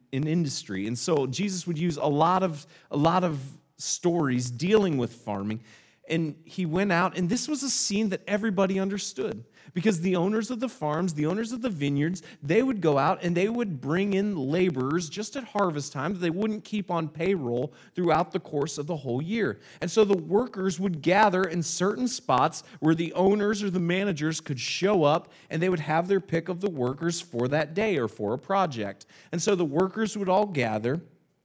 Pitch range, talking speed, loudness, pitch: 150-200 Hz, 205 wpm, -27 LUFS, 175 Hz